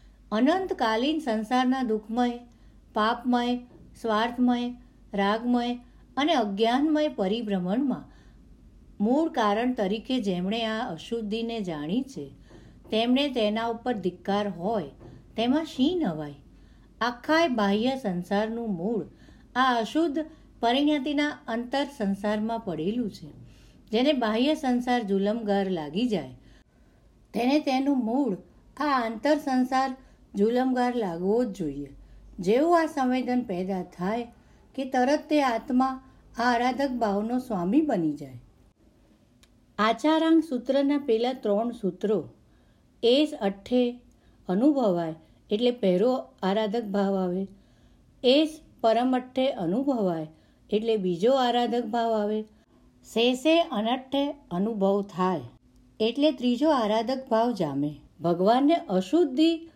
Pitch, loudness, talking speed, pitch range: 230 Hz, -26 LUFS, 85 wpm, 200-260 Hz